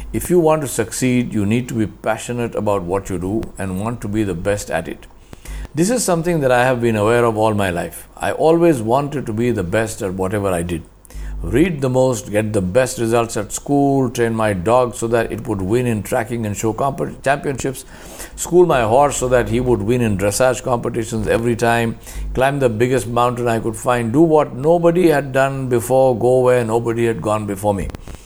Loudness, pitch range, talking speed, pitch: -17 LUFS, 105-130 Hz, 215 wpm, 115 Hz